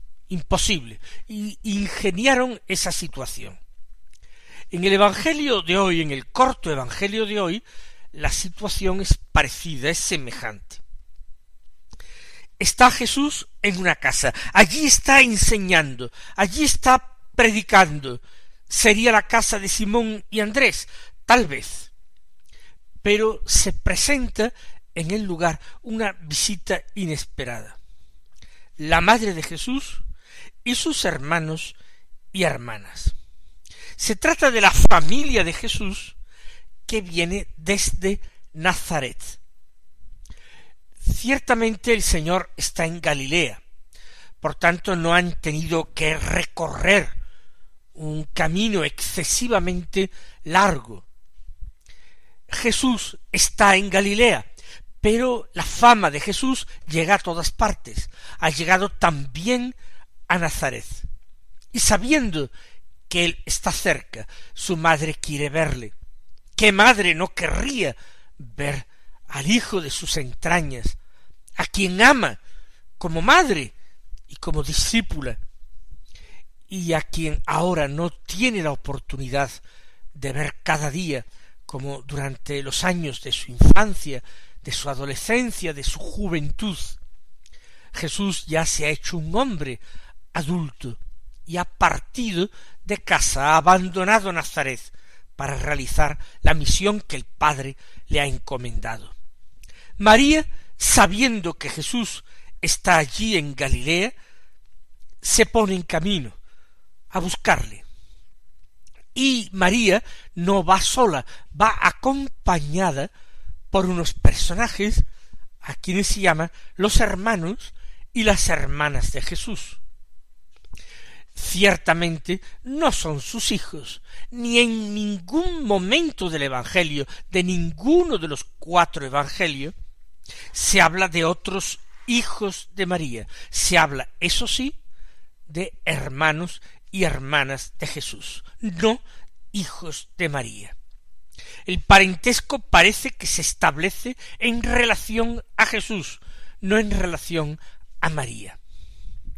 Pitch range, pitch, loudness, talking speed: 145-215 Hz, 180 Hz, -21 LUFS, 110 wpm